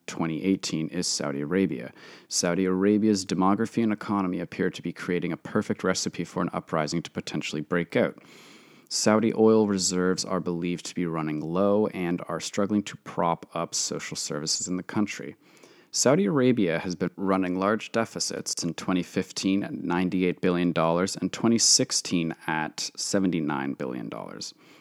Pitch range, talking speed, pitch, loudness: 85-100 Hz, 145 wpm, 90 Hz, -26 LUFS